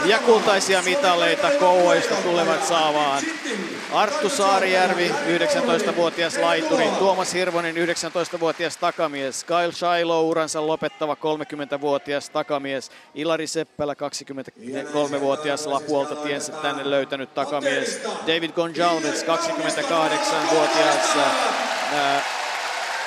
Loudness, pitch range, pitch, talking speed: -21 LUFS, 145-175 Hz, 160 Hz, 80 wpm